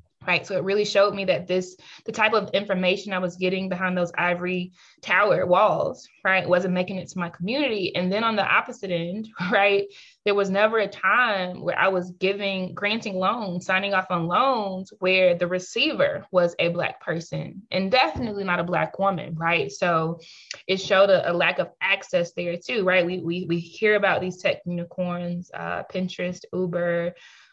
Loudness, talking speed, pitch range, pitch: -23 LUFS, 185 wpm, 175-200 Hz, 185 Hz